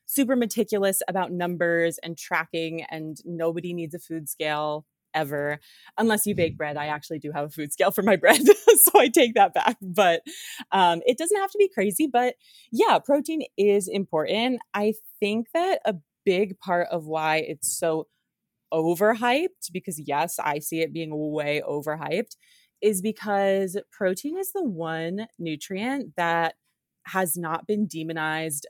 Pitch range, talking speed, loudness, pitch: 160-220 Hz, 160 wpm, -24 LUFS, 180 Hz